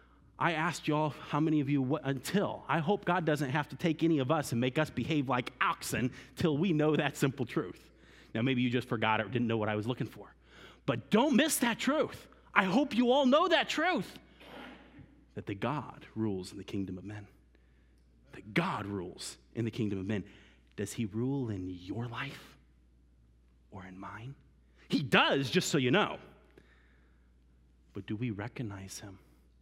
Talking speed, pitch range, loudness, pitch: 190 wpm, 95-150 Hz, -32 LUFS, 120 Hz